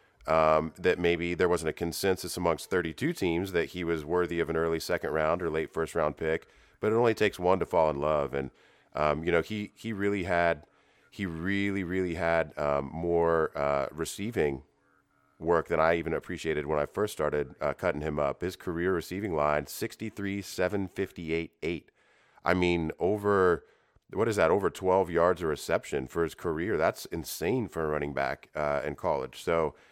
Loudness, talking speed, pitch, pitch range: -29 LUFS, 185 wpm, 85 Hz, 80-95 Hz